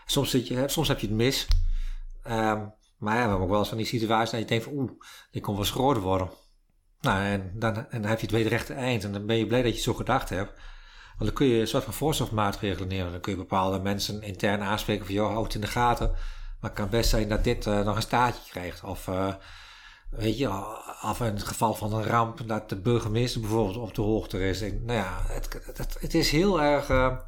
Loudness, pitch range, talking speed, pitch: -28 LUFS, 100-120 Hz, 250 wpm, 110 Hz